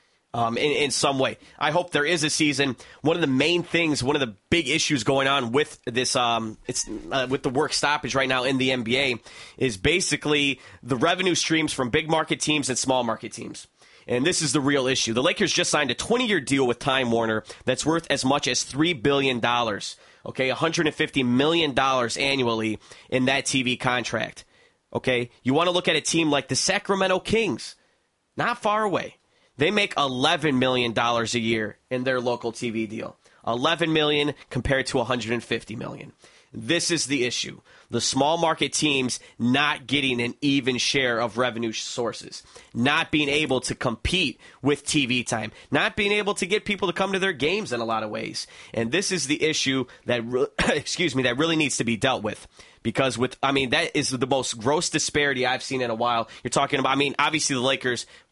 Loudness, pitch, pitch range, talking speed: -23 LUFS, 135 Hz, 120-155 Hz, 200 wpm